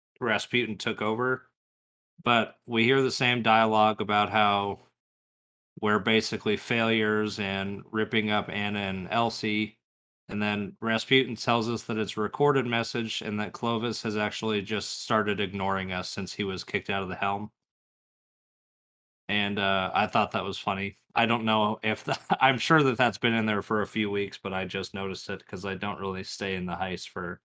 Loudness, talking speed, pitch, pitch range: -27 LUFS, 185 wpm, 105 Hz, 100-115 Hz